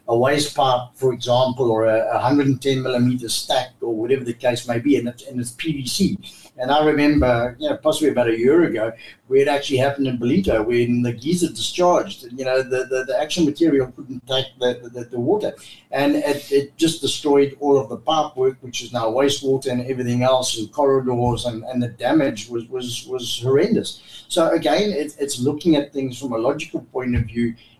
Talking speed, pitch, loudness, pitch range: 205 wpm, 130 Hz, -20 LUFS, 120-145 Hz